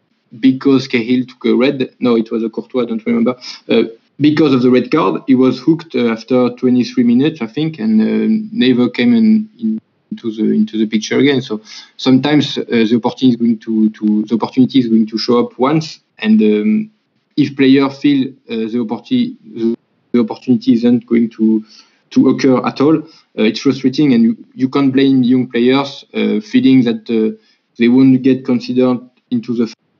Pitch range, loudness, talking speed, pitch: 120-160 Hz, -14 LUFS, 190 wpm, 130 Hz